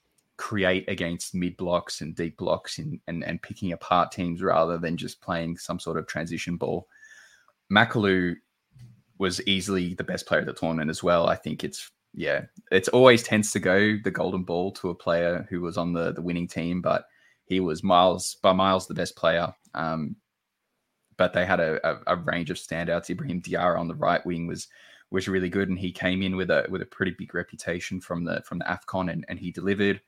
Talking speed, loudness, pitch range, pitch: 205 wpm, -26 LUFS, 85-95 Hz, 90 Hz